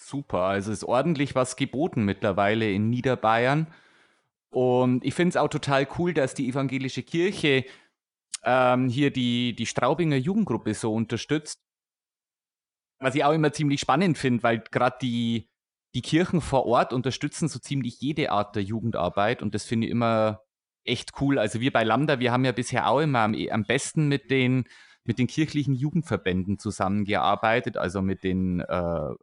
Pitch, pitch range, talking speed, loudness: 125 Hz, 110-140 Hz, 165 wpm, -25 LUFS